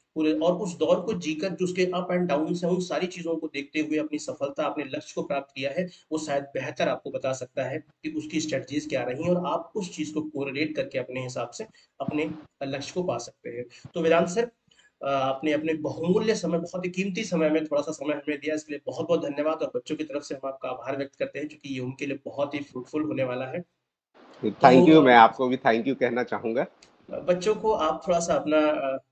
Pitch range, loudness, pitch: 140-175 Hz, -26 LUFS, 155 Hz